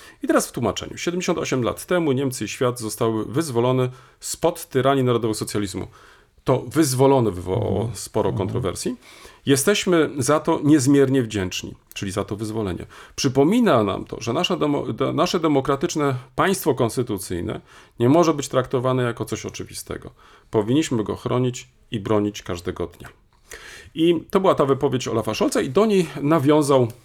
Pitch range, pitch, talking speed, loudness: 110-150 Hz, 130 Hz, 145 wpm, -21 LUFS